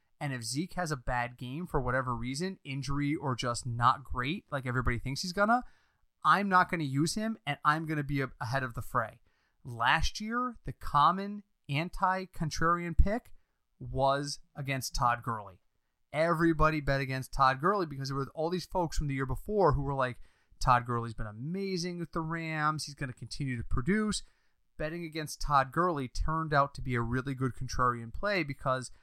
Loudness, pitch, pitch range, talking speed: -32 LUFS, 140 Hz, 130-170 Hz, 180 wpm